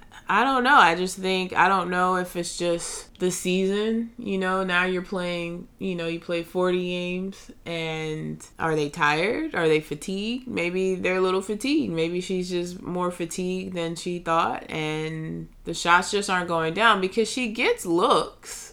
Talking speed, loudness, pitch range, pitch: 180 wpm, -24 LUFS, 170-190 Hz, 180 Hz